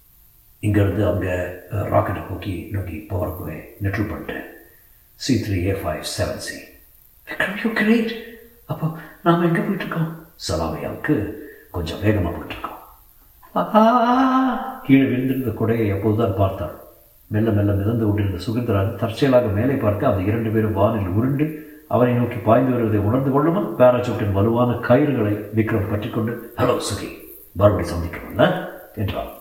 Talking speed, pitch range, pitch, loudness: 120 wpm, 100-135 Hz, 110 Hz, -21 LUFS